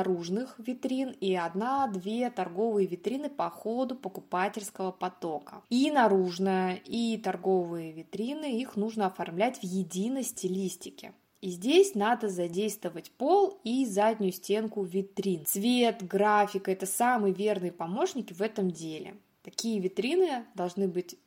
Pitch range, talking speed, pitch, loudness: 185-235 Hz, 120 wpm, 200 Hz, -30 LUFS